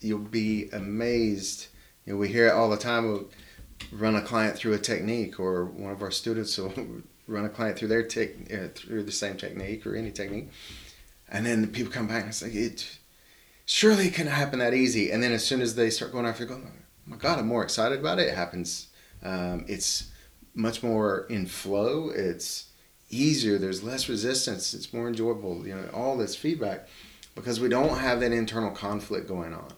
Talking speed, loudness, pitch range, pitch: 205 wpm, -28 LUFS, 100-115 Hz, 110 Hz